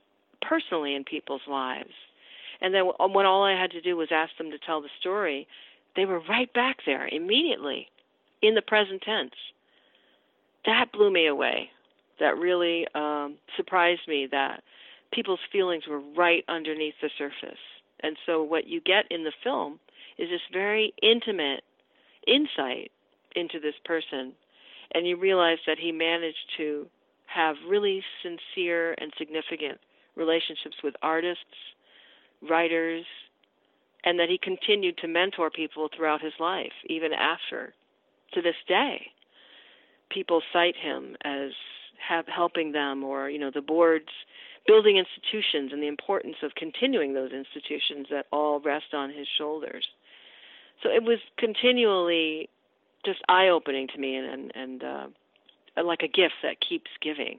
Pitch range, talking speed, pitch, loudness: 150-190 Hz, 145 wpm, 165 Hz, -27 LUFS